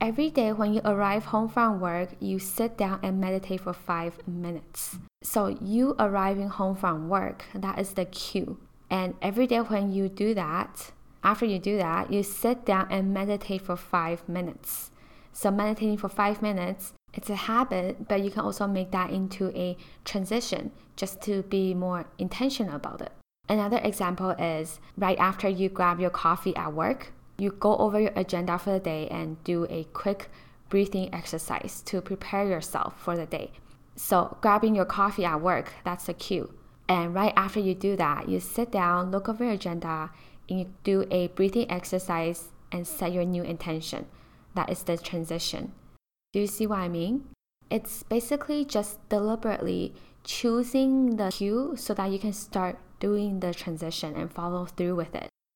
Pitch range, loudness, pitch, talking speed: 175-210 Hz, -28 LUFS, 190 Hz, 175 wpm